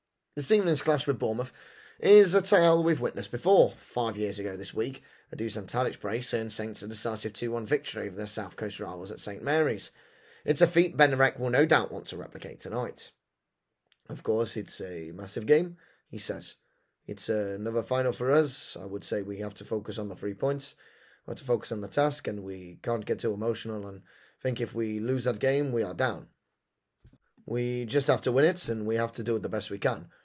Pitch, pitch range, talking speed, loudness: 115 Hz, 105-140 Hz, 215 wpm, -29 LUFS